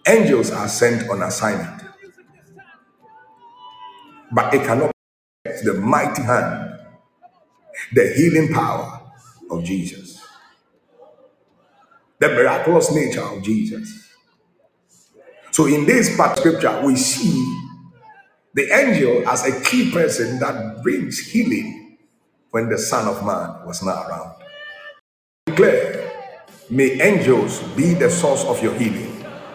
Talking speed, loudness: 110 wpm, -18 LUFS